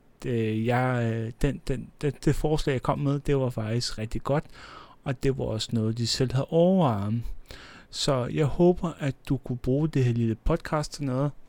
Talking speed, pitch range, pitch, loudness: 190 wpm, 115-145 Hz, 135 Hz, -27 LUFS